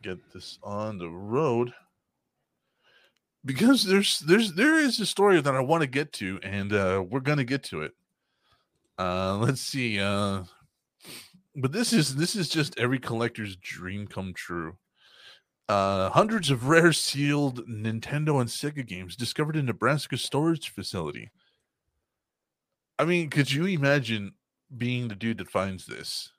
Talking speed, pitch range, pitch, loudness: 150 wpm, 105-155 Hz, 130 Hz, -26 LUFS